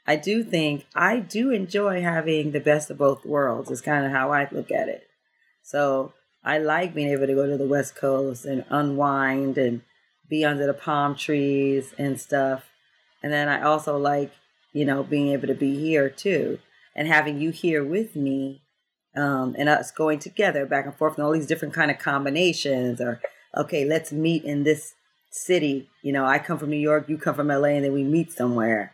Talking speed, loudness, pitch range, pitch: 205 wpm, -24 LUFS, 140-155 Hz, 145 Hz